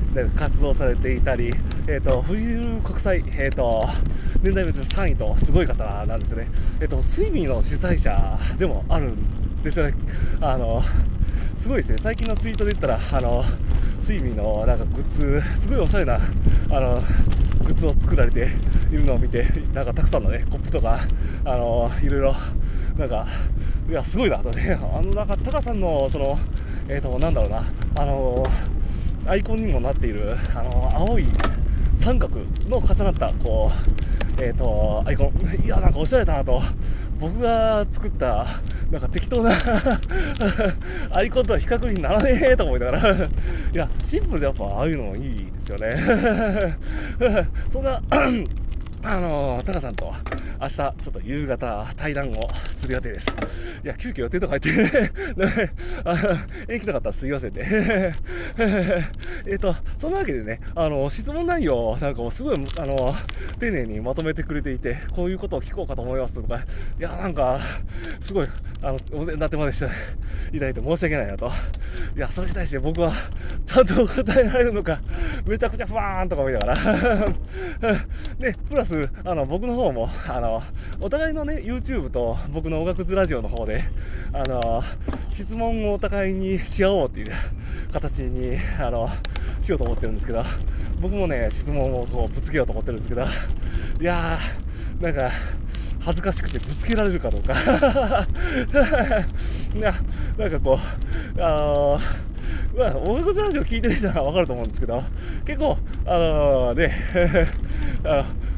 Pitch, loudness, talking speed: 120 Hz, -24 LUFS, 330 characters per minute